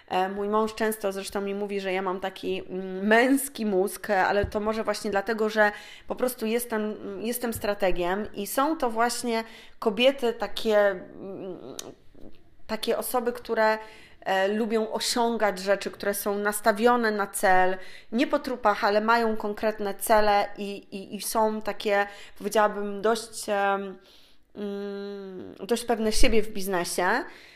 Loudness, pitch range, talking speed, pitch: -26 LUFS, 200-225 Hz, 130 wpm, 210 Hz